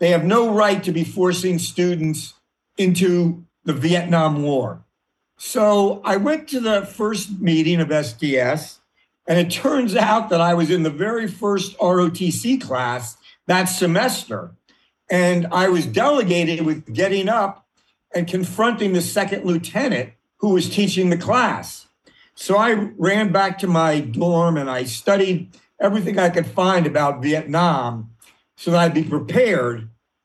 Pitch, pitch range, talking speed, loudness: 175 Hz, 160-200 Hz, 145 wpm, -19 LUFS